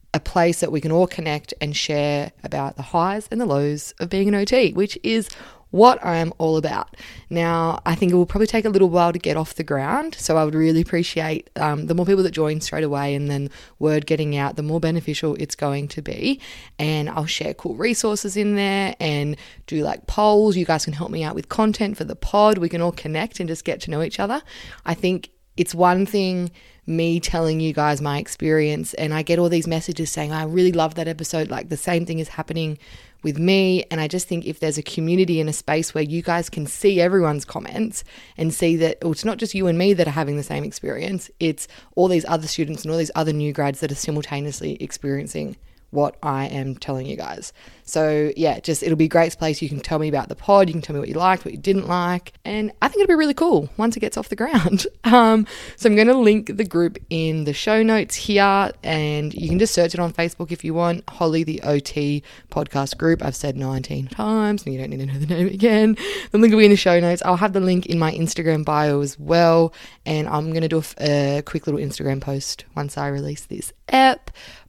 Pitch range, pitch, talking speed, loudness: 150-185 Hz, 165 Hz, 240 wpm, -21 LUFS